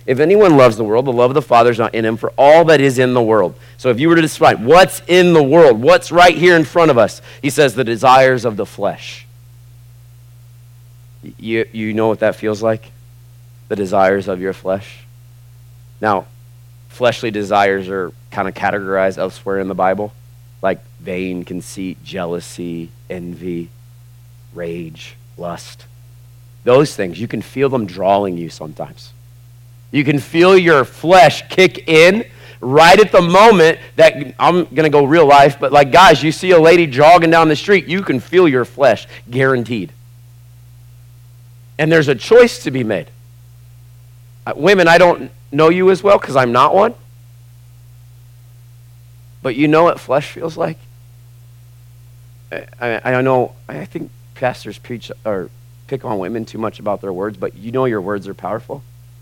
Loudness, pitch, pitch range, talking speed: -13 LUFS, 120 Hz, 120-140 Hz, 170 wpm